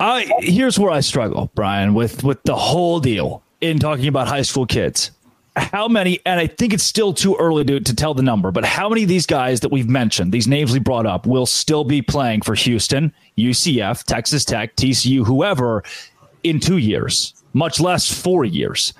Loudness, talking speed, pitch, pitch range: -17 LUFS, 200 wpm, 140 Hz, 125-170 Hz